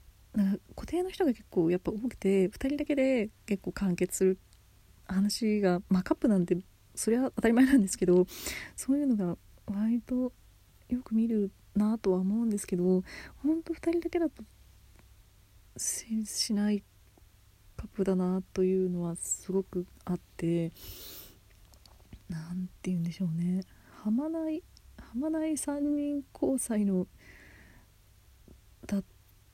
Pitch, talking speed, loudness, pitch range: 190 Hz, 250 characters per minute, -31 LUFS, 165-230 Hz